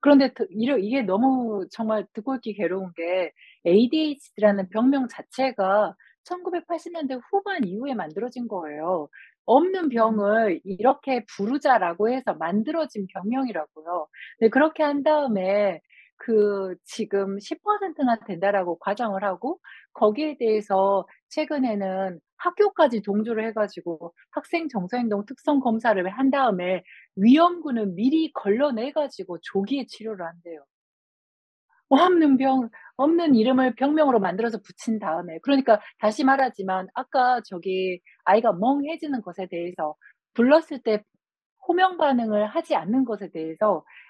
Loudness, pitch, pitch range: -24 LUFS, 225 Hz, 195-275 Hz